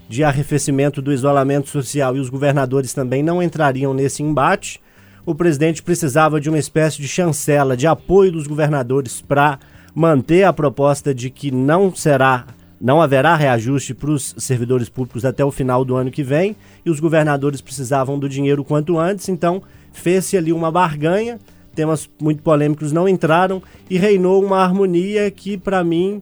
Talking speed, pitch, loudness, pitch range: 165 wpm, 150 Hz, -17 LUFS, 140-170 Hz